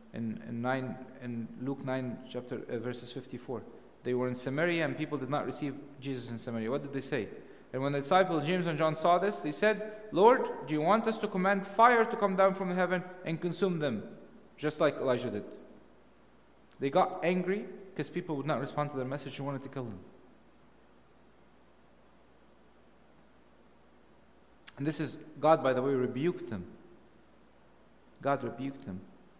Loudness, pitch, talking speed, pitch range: -32 LUFS, 145 Hz, 175 wpm, 130-180 Hz